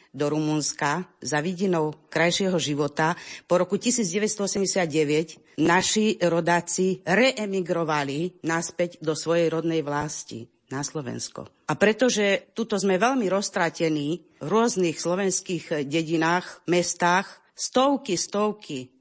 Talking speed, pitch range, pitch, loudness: 100 wpm, 155-195 Hz, 175 Hz, -24 LUFS